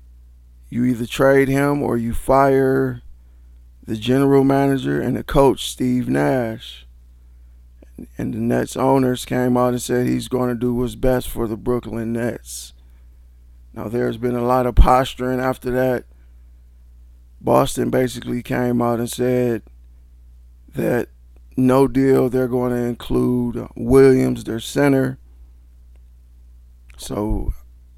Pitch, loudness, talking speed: 115 Hz, -19 LUFS, 125 wpm